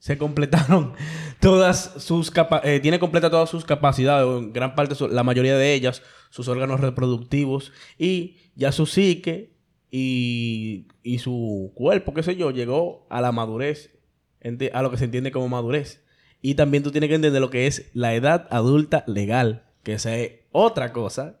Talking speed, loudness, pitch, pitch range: 170 wpm, -22 LUFS, 140 Hz, 125-155 Hz